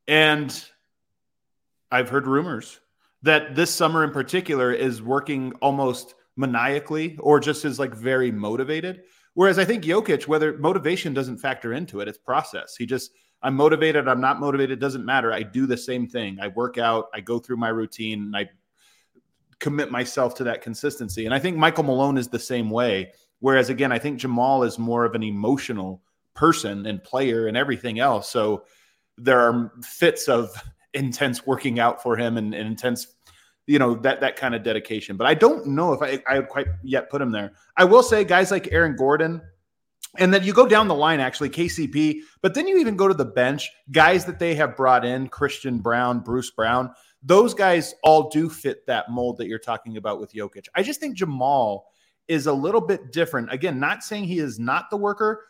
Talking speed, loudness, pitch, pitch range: 195 wpm, -22 LUFS, 135 Hz, 120-155 Hz